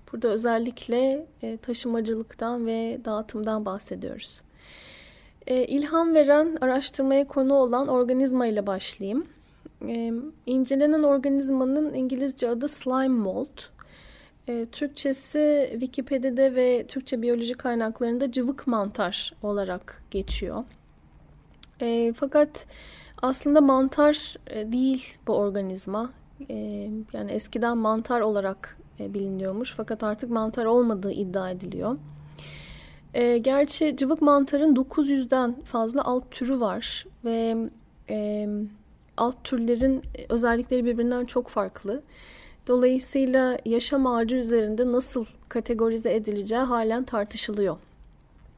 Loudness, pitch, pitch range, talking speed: -25 LUFS, 245 Hz, 225-265 Hz, 90 wpm